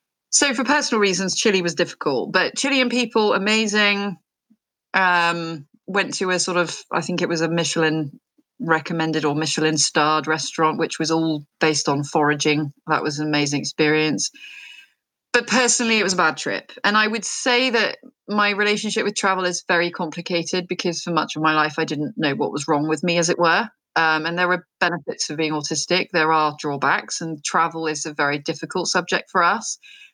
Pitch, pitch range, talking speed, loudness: 170 Hz, 155-205 Hz, 190 wpm, -20 LUFS